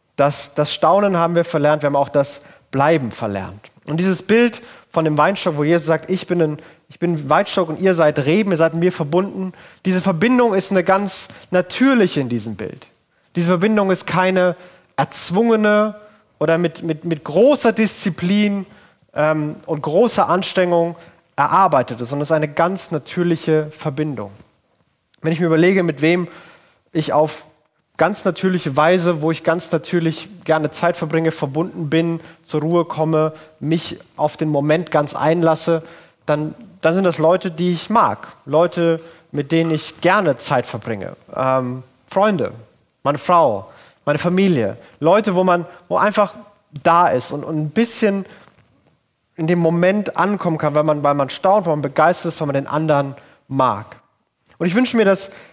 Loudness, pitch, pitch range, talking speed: -18 LUFS, 165 Hz, 150-185 Hz, 165 wpm